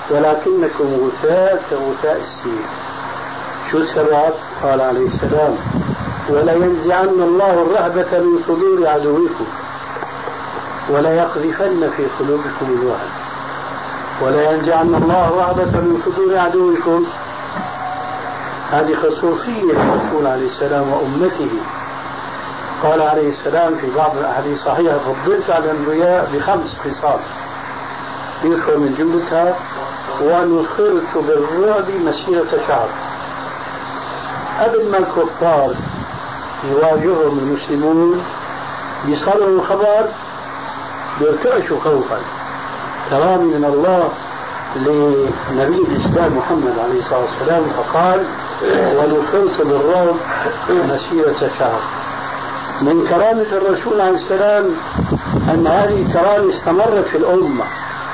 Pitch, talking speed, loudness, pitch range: 170 Hz, 85 wpm, -16 LUFS, 150-195 Hz